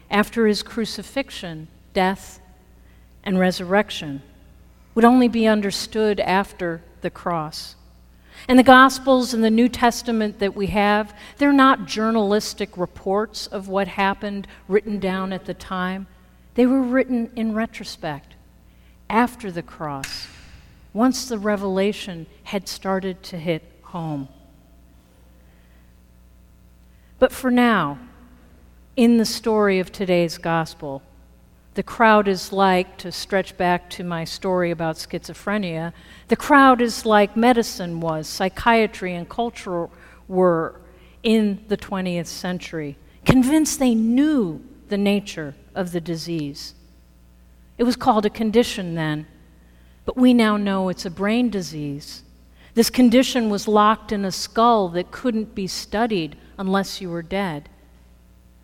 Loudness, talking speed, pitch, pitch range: -20 LUFS, 125 wpm, 195 Hz, 160-220 Hz